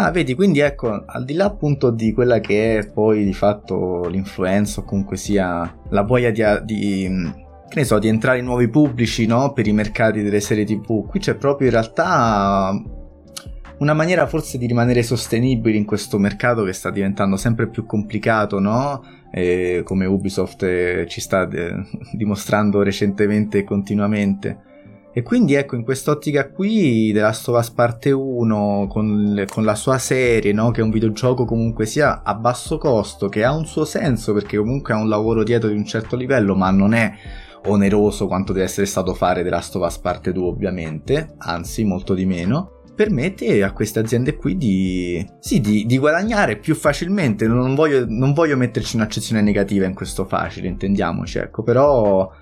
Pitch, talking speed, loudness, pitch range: 105 Hz, 180 wpm, -19 LUFS, 100-125 Hz